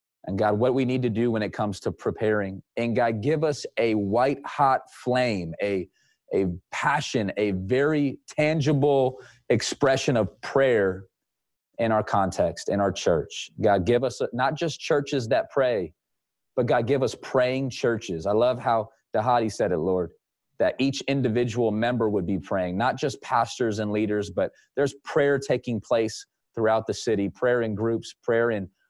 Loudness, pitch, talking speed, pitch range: -25 LUFS, 115 Hz, 170 wpm, 105-130 Hz